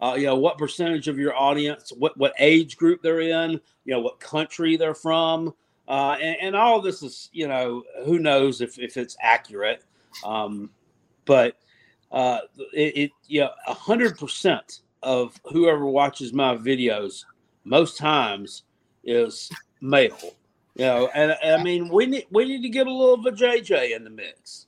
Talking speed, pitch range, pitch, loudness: 180 wpm, 135-170 Hz, 155 Hz, -22 LUFS